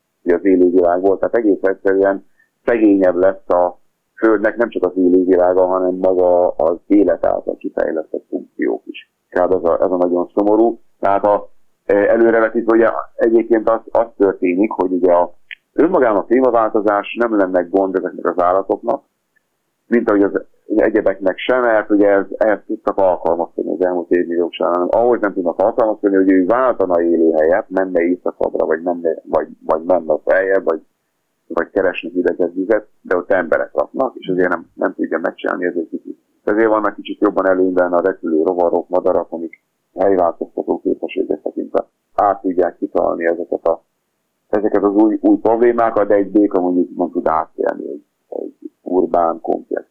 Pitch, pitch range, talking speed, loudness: 95 Hz, 90-110 Hz, 160 wpm, -16 LUFS